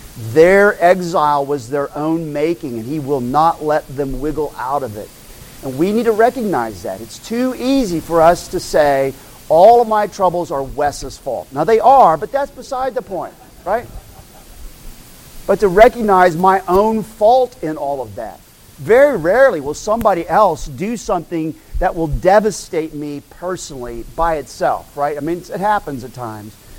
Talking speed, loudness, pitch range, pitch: 170 wpm, -15 LUFS, 145-210 Hz, 165 Hz